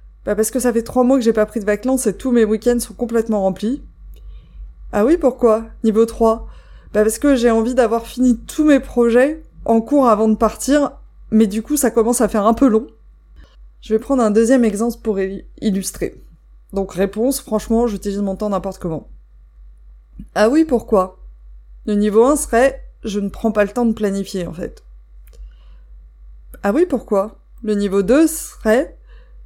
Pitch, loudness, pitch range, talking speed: 220 Hz, -17 LUFS, 195-245 Hz, 185 wpm